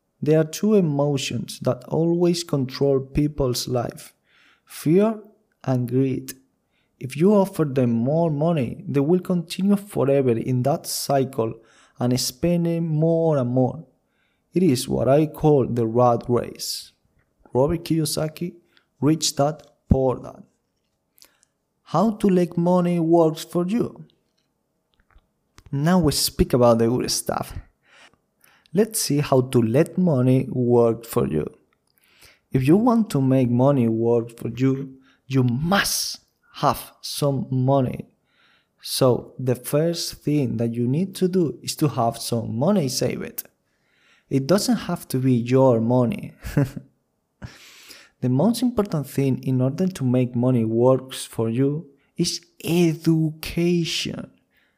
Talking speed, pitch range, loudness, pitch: 130 wpm, 125-170 Hz, -22 LUFS, 140 Hz